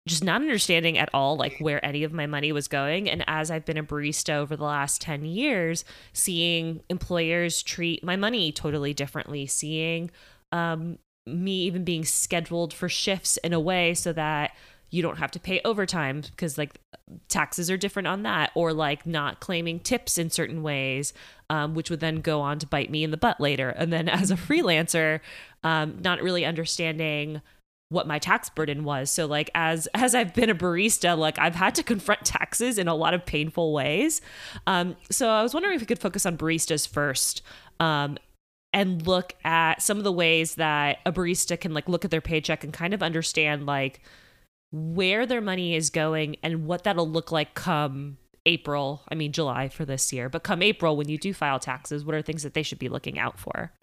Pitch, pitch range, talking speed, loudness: 165 Hz, 150-180 Hz, 205 wpm, -26 LUFS